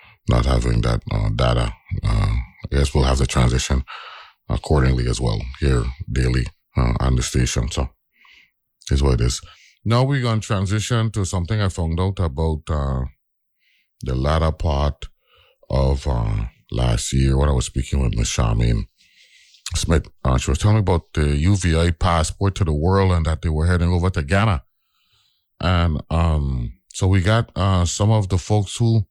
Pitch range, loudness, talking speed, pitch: 65-95 Hz, -21 LUFS, 170 wpm, 80 Hz